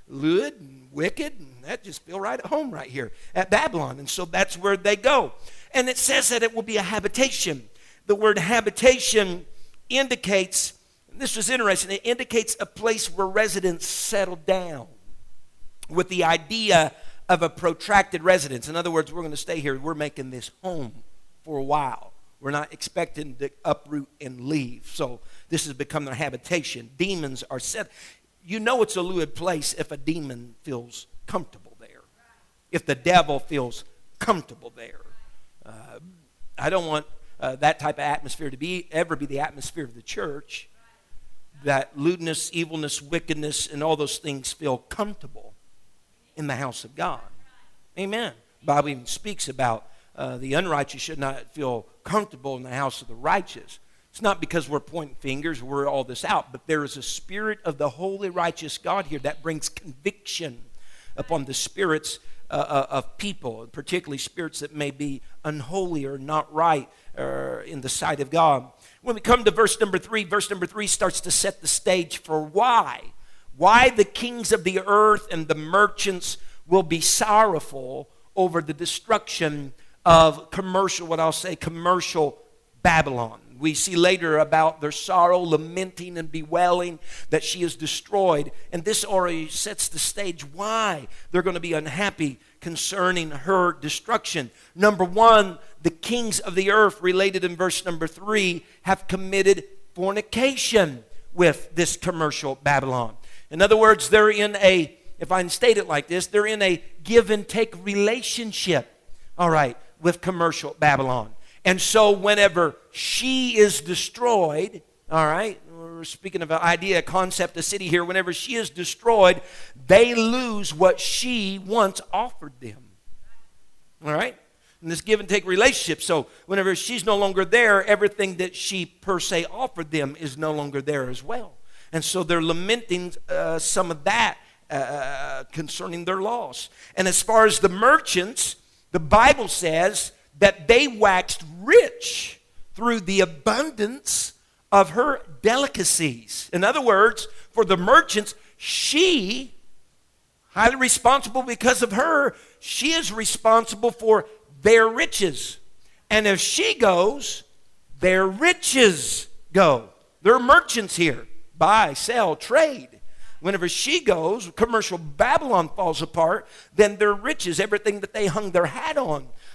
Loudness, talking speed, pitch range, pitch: -22 LUFS, 155 wpm, 150-210 Hz, 175 Hz